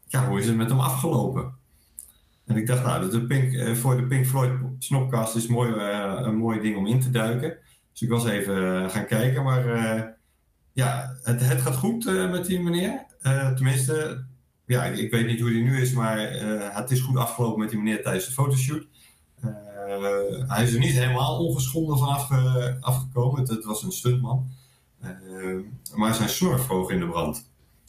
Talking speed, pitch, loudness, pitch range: 200 wpm, 125 Hz, -25 LUFS, 110-130 Hz